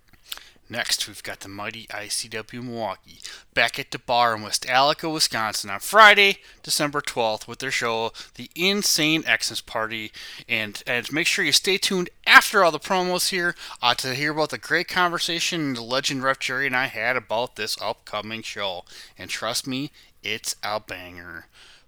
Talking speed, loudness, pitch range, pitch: 170 wpm, -22 LUFS, 115-160 Hz, 130 Hz